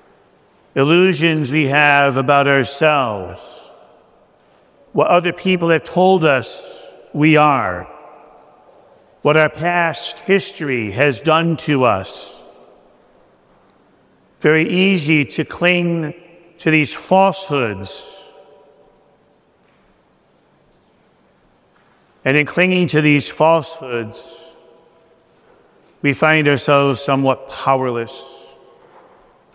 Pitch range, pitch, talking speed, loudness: 140-170 Hz, 155 Hz, 80 wpm, -15 LUFS